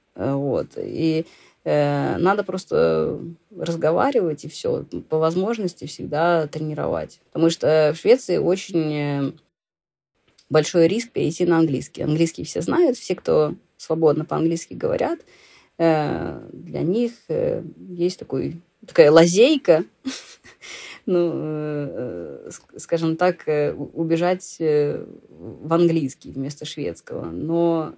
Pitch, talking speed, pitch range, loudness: 165 Hz, 100 wpm, 155-180 Hz, -21 LUFS